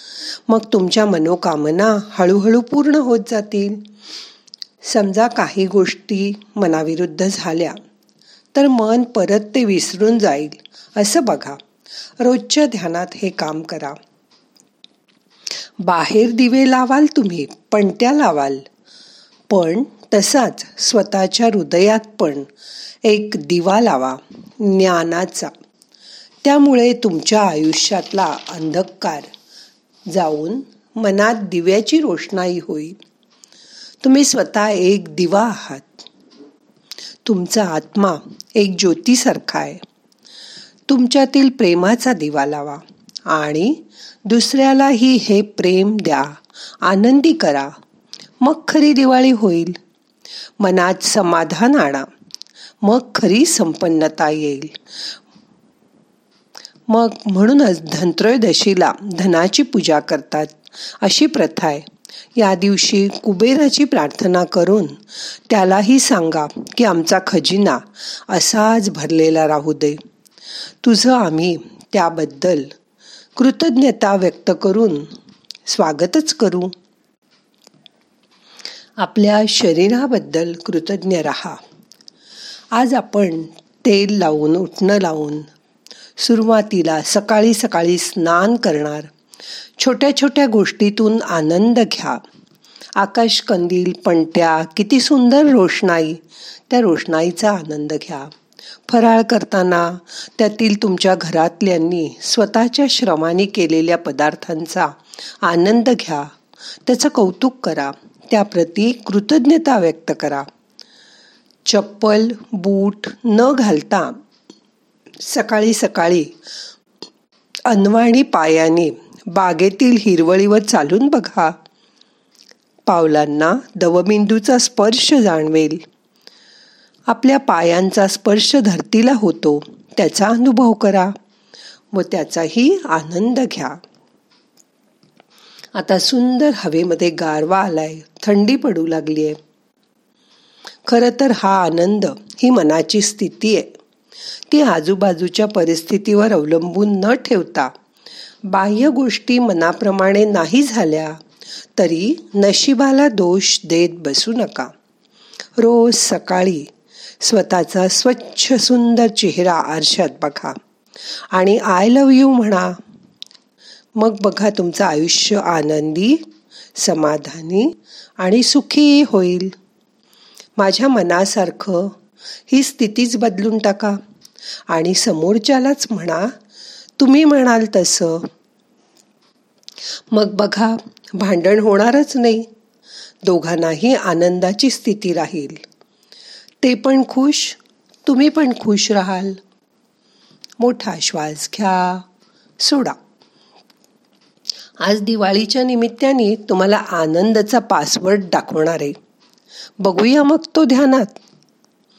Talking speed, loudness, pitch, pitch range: 85 wpm, -15 LUFS, 205 Hz, 175-235 Hz